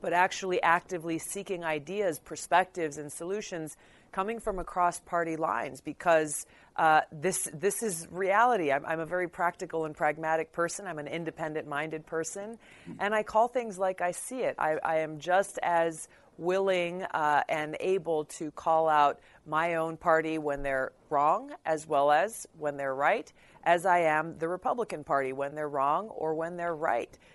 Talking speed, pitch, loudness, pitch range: 170 wpm, 165 Hz, -30 LUFS, 155-180 Hz